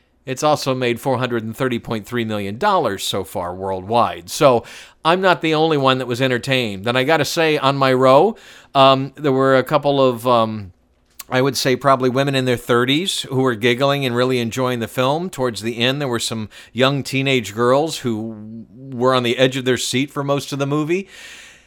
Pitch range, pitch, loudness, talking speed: 120-140 Hz, 130 Hz, -18 LUFS, 195 wpm